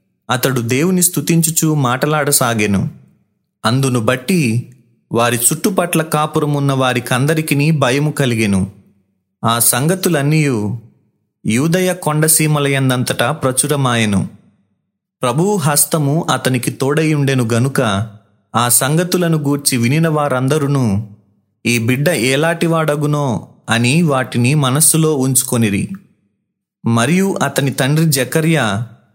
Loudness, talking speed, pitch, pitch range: -14 LUFS, 80 wpm, 140 Hz, 120-155 Hz